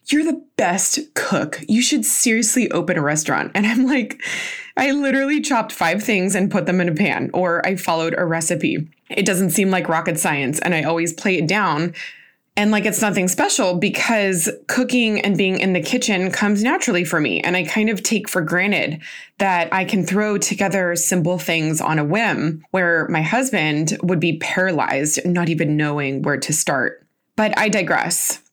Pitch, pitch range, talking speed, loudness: 190 Hz, 170-215 Hz, 185 wpm, -18 LUFS